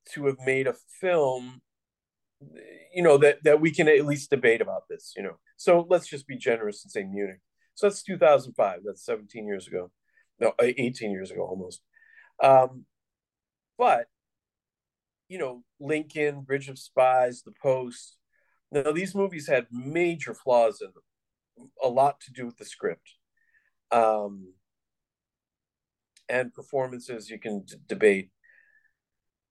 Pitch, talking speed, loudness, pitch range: 140 Hz, 140 wpm, -25 LUFS, 120-195 Hz